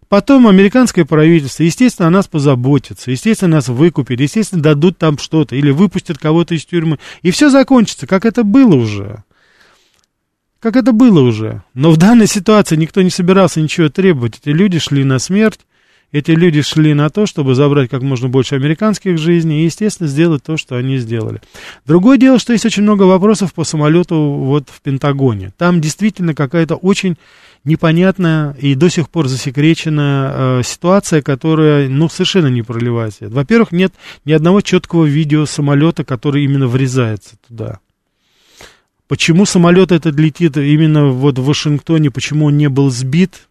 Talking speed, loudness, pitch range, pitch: 160 wpm, -12 LUFS, 140-185 Hz, 155 Hz